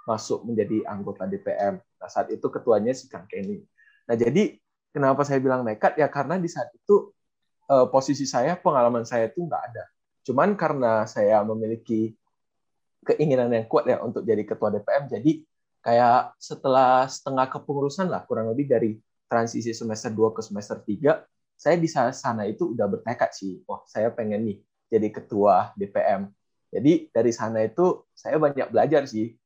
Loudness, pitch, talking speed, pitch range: -24 LUFS, 135 Hz, 160 wpm, 115-175 Hz